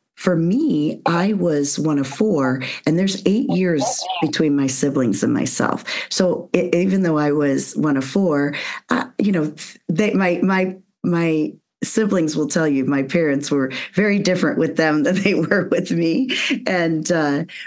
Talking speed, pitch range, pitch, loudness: 170 wpm, 150-195 Hz, 170 Hz, -19 LUFS